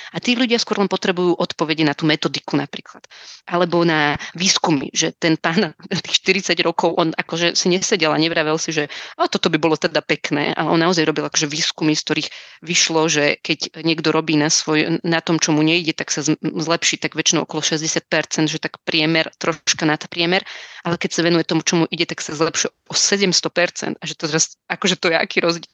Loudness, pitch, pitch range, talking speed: -18 LUFS, 165 Hz, 155-175 Hz, 210 wpm